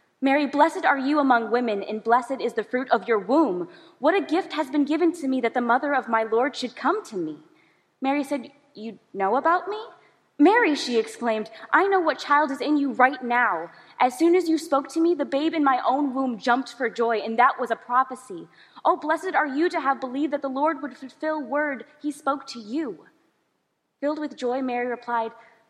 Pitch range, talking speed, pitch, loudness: 240-310 Hz, 215 wpm, 275 Hz, -24 LUFS